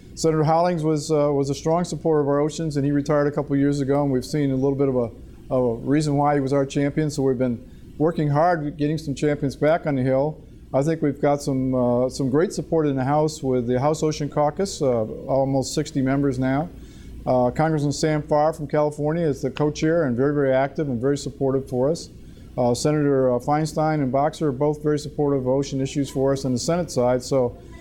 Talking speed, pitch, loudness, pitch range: 225 wpm, 145 Hz, -22 LUFS, 135-150 Hz